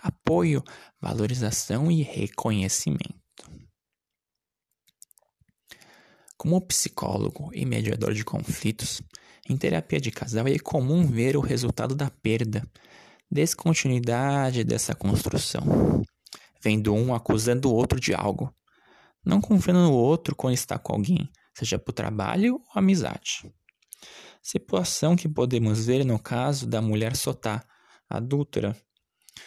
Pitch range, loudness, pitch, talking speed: 110-155 Hz, -25 LUFS, 125 Hz, 110 wpm